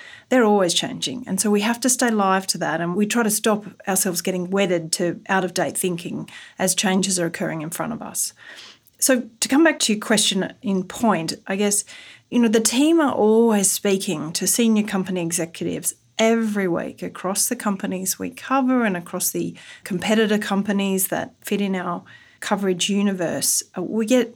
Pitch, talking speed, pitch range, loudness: 200 Hz, 185 wpm, 185-225 Hz, -21 LUFS